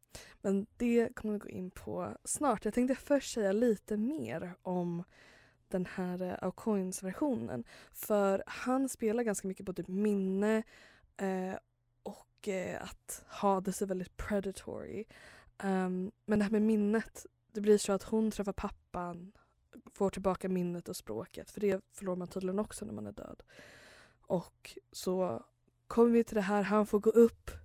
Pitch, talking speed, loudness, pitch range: 200 Hz, 155 wpm, -34 LUFS, 185-220 Hz